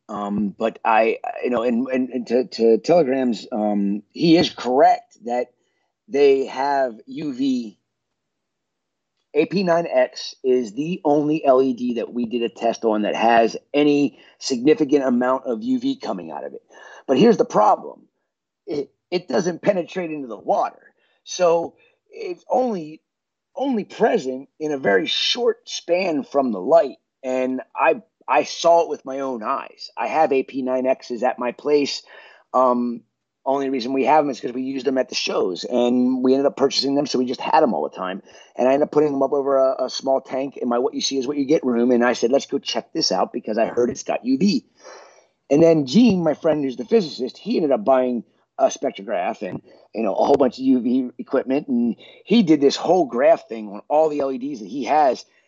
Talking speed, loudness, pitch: 195 wpm, -20 LUFS, 140 Hz